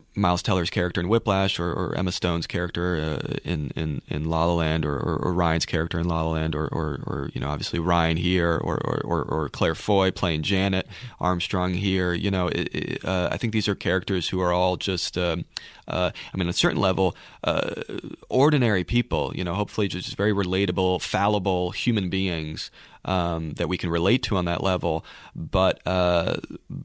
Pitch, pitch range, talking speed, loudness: 90 Hz, 85-95 Hz, 195 wpm, -25 LUFS